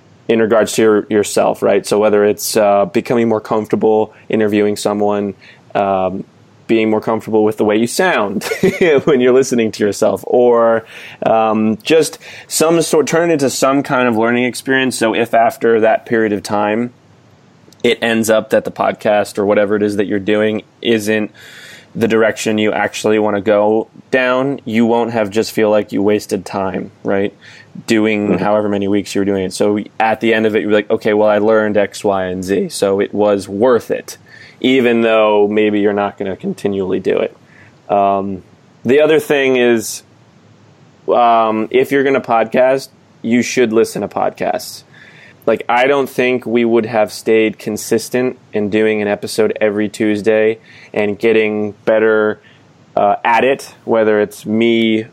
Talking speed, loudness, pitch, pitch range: 175 wpm, -14 LUFS, 110 Hz, 105-115 Hz